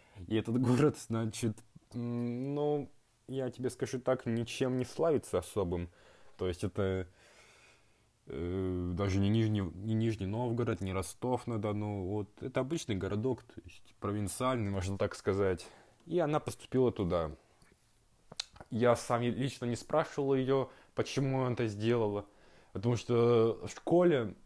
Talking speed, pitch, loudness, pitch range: 135 wpm, 115 Hz, -34 LUFS, 105-130 Hz